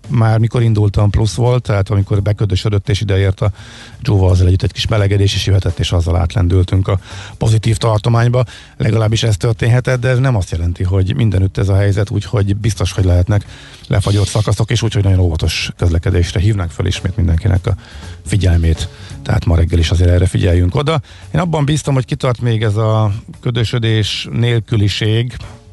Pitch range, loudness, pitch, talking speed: 95-115 Hz, -15 LUFS, 105 Hz, 170 wpm